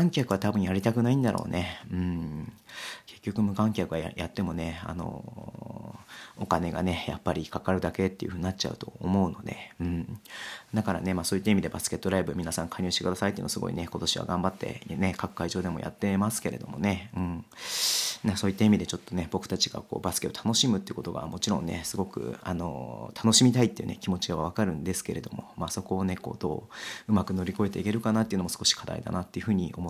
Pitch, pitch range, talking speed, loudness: 95 Hz, 85-105 Hz, 490 characters per minute, -29 LUFS